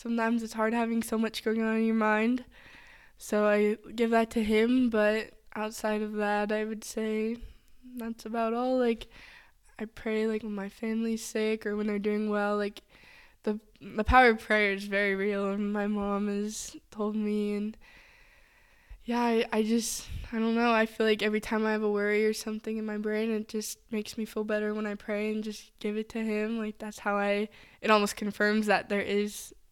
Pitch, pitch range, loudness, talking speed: 215 Hz, 210-225 Hz, -29 LUFS, 205 wpm